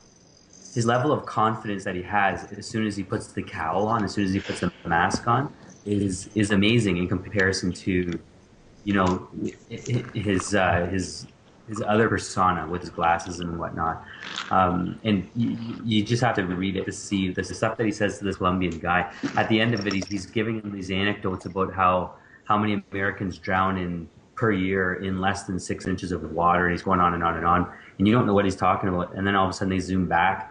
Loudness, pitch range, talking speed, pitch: -25 LUFS, 90-105 Hz, 225 wpm, 95 Hz